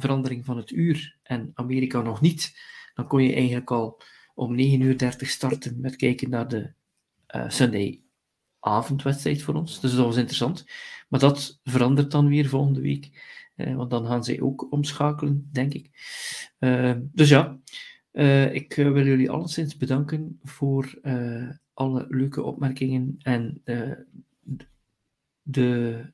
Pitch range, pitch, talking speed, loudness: 125-145 Hz, 135 Hz, 150 wpm, -24 LUFS